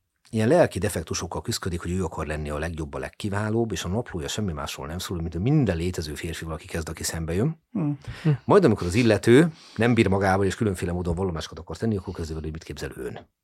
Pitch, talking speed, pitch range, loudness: 95 Hz, 215 wpm, 85-115 Hz, -25 LUFS